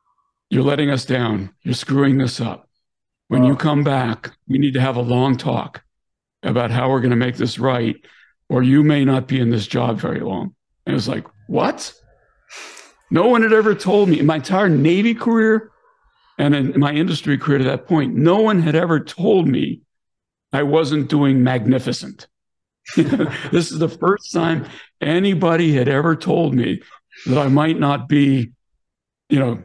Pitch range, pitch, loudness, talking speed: 125-165 Hz, 140 Hz, -18 LUFS, 180 wpm